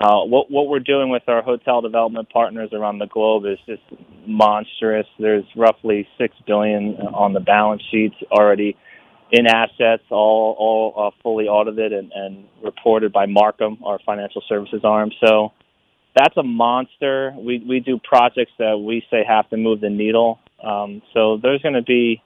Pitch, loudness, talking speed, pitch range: 110 Hz, -18 LUFS, 170 wpm, 105-115 Hz